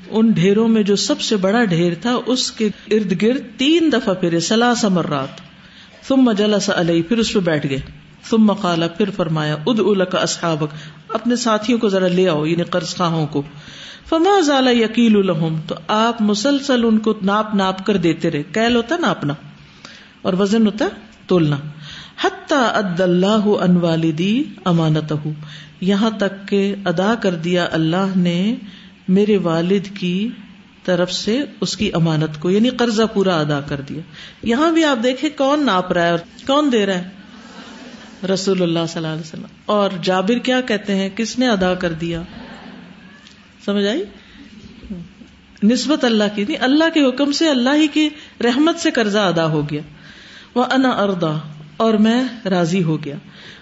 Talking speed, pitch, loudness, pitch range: 160 wpm, 200 Hz, -17 LUFS, 175-230 Hz